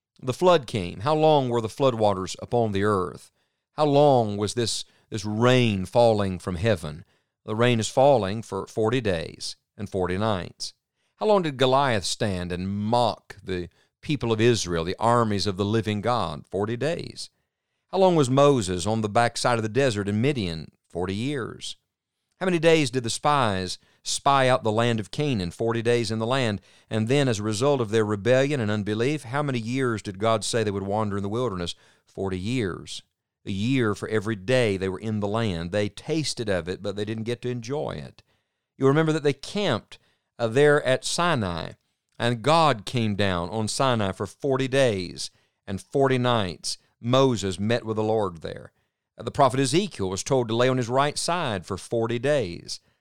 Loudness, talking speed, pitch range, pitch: -24 LUFS, 190 wpm, 100-130 Hz, 115 Hz